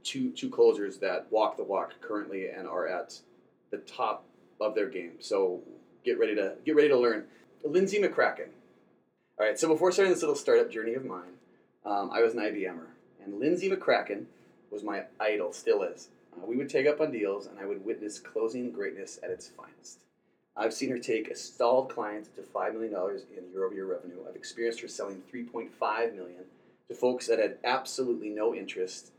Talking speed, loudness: 190 wpm, -30 LUFS